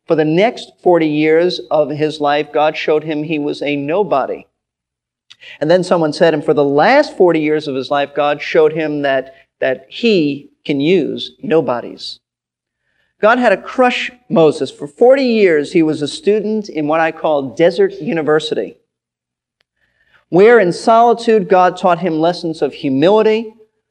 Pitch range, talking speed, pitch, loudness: 150-205 Hz, 160 wpm, 160 Hz, -14 LUFS